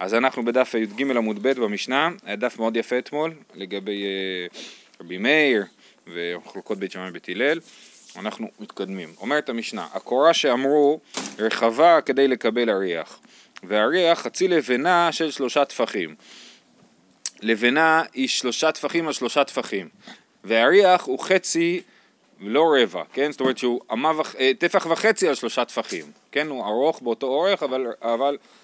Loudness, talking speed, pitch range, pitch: -22 LUFS, 140 wpm, 115-160 Hz, 130 Hz